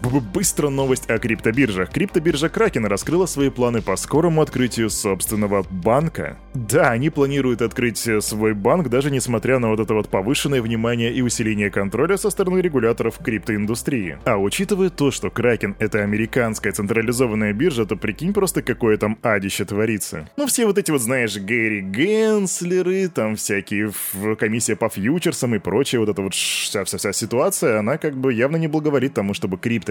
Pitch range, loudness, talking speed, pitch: 110-150 Hz, -20 LUFS, 165 wpm, 120 Hz